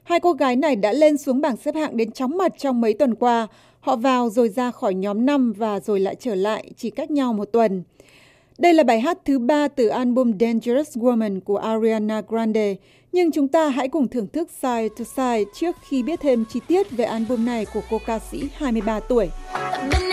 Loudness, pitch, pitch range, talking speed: -21 LUFS, 245 Hz, 220-285 Hz, 215 wpm